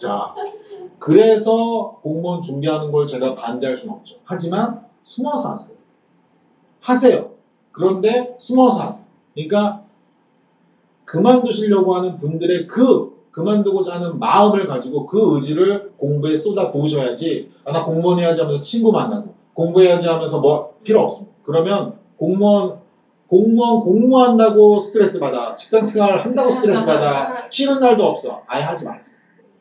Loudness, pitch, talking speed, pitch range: -16 LUFS, 200 Hz, 325 characters per minute, 165-225 Hz